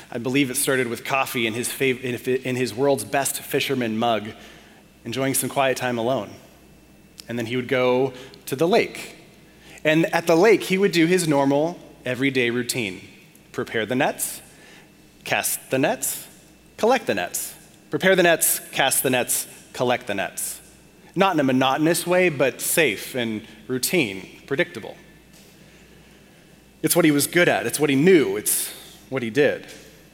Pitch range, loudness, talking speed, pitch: 125-170 Hz, -21 LUFS, 160 wpm, 135 Hz